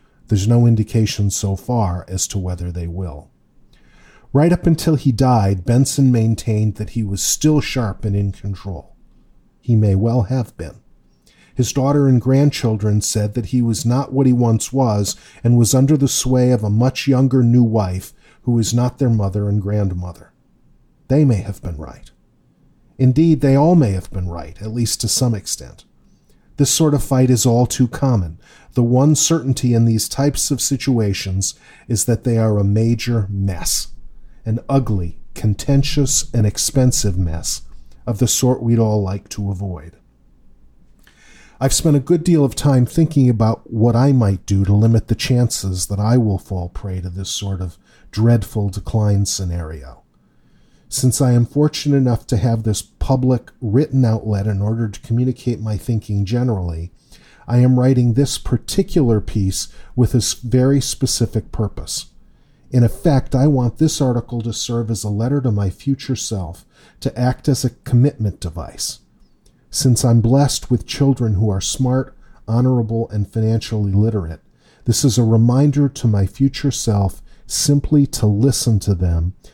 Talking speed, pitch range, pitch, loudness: 165 wpm, 100-130 Hz, 115 Hz, -17 LUFS